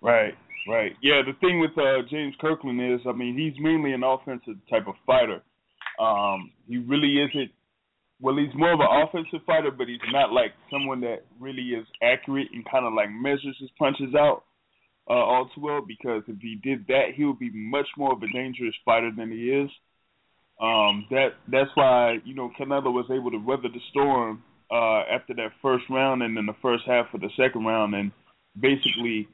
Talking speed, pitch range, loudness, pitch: 200 wpm, 120-140 Hz, -25 LUFS, 130 Hz